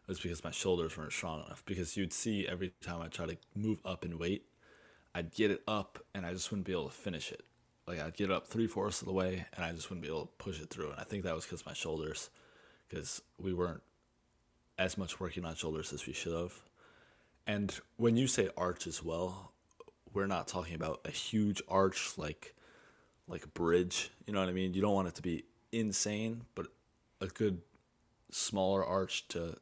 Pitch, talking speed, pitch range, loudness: 95 Hz, 215 wpm, 85-100 Hz, -37 LUFS